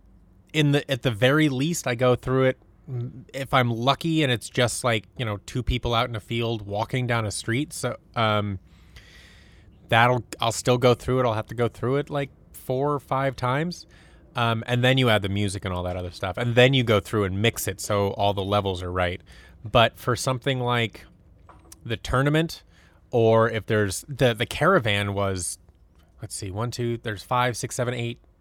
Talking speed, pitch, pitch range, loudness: 205 wpm, 115 Hz, 95-125 Hz, -24 LUFS